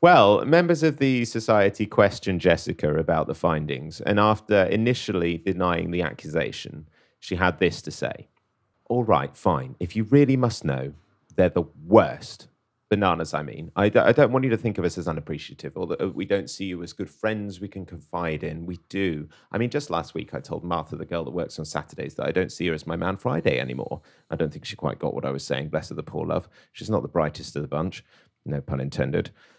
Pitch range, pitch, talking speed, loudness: 80-110 Hz, 90 Hz, 225 wpm, -24 LUFS